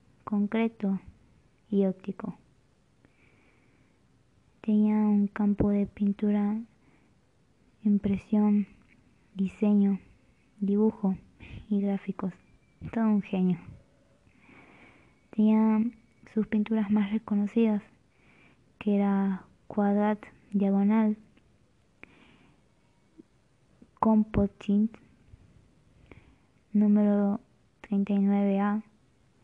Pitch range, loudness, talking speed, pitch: 200-215 Hz, -28 LUFS, 55 wpm, 205 Hz